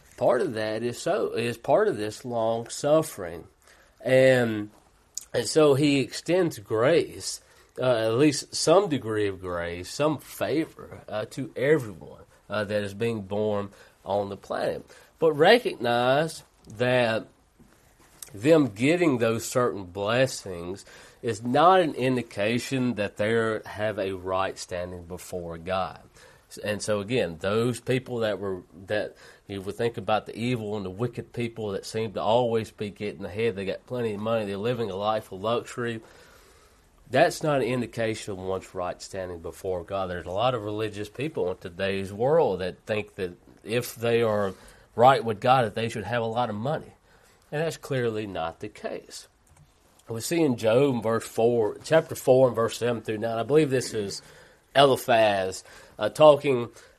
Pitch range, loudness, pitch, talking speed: 100-125 Hz, -26 LUFS, 115 Hz, 165 wpm